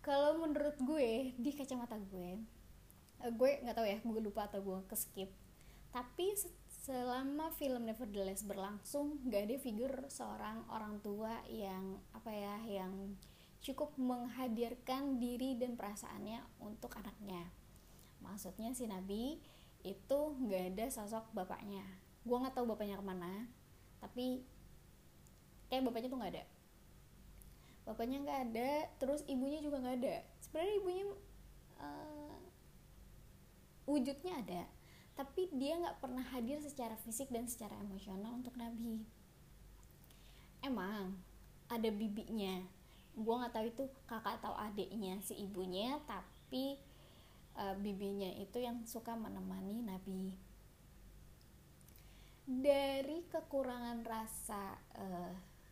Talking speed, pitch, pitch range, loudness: 115 wpm, 235 Hz, 205-265 Hz, -43 LUFS